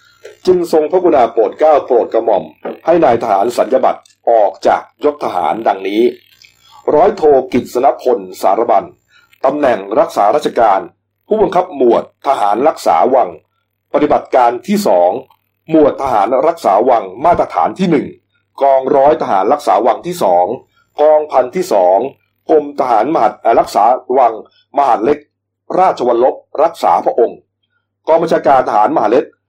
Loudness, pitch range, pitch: -12 LUFS, 135-185 Hz, 155 Hz